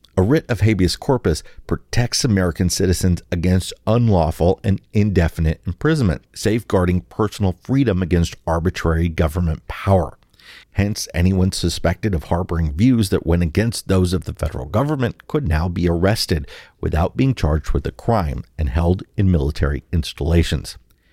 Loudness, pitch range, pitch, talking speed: -19 LUFS, 85-105 Hz, 90 Hz, 140 wpm